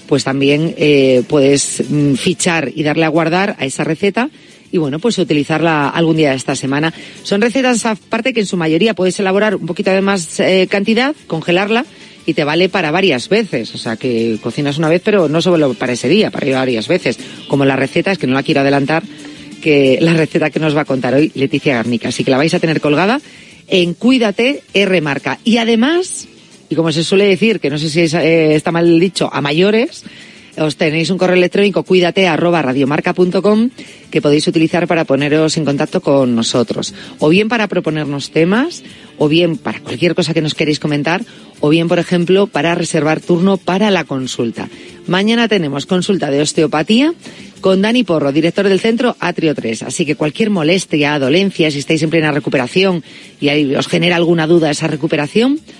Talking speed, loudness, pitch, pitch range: 195 wpm, -14 LUFS, 165 Hz, 145-190 Hz